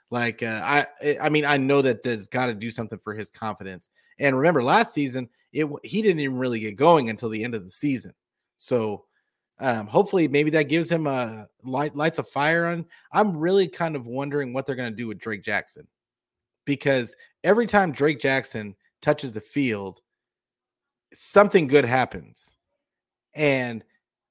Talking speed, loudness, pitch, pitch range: 175 wpm, -23 LUFS, 140 Hz, 115-150 Hz